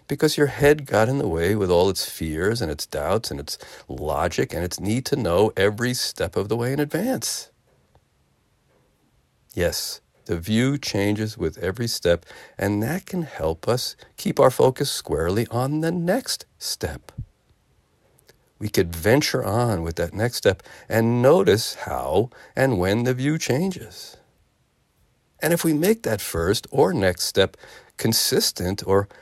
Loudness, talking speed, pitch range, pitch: -22 LUFS, 155 wpm, 100-145 Hz, 120 Hz